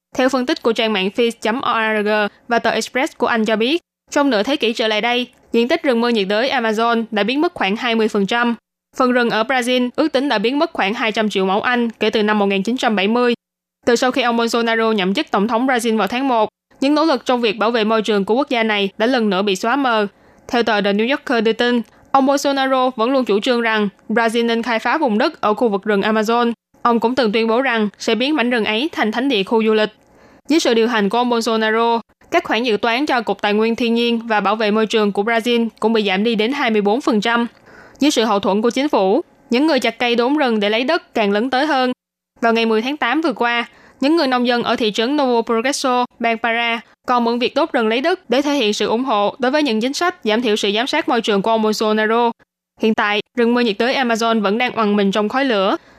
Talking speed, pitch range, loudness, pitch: 250 wpm, 220-255 Hz, -17 LUFS, 235 Hz